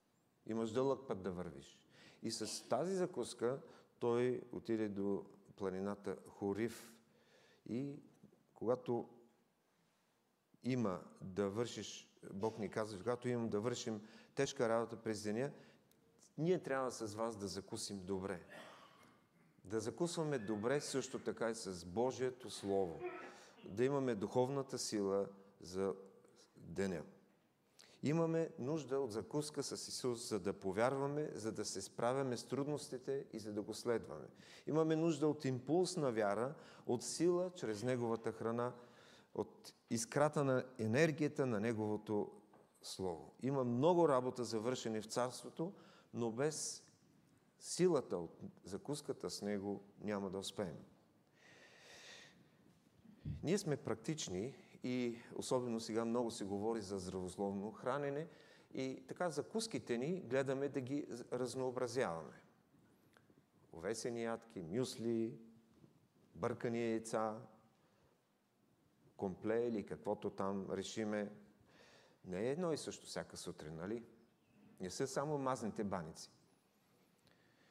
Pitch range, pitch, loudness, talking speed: 105-135 Hz, 120 Hz, -41 LUFS, 115 wpm